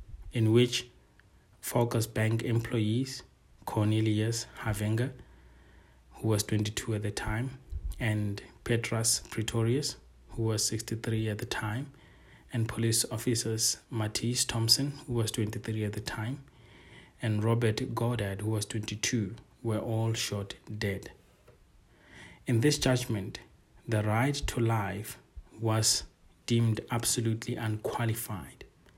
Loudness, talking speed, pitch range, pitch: -31 LUFS, 110 wpm, 110-120 Hz, 115 Hz